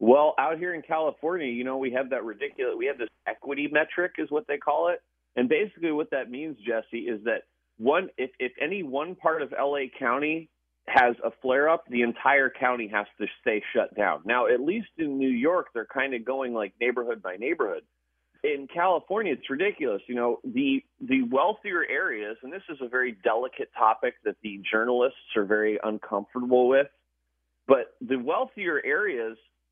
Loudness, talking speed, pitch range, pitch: -27 LUFS, 185 wpm, 120-195 Hz, 135 Hz